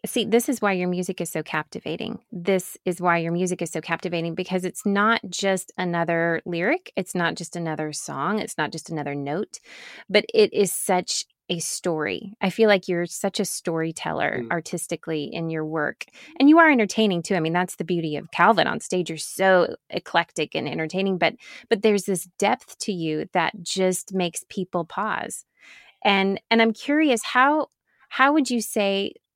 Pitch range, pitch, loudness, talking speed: 170-215 Hz, 185 Hz, -23 LUFS, 185 wpm